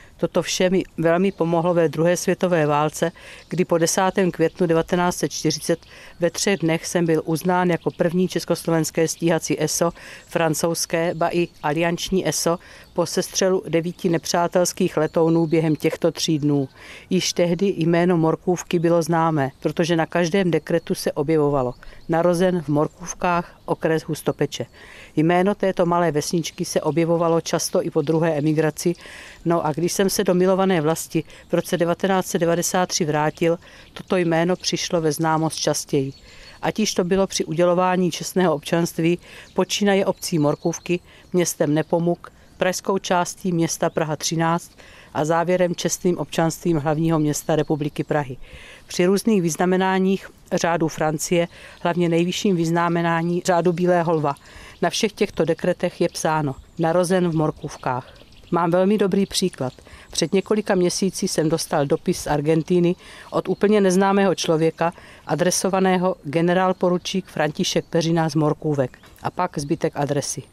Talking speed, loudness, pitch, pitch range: 135 wpm, -21 LUFS, 170 Hz, 160-180 Hz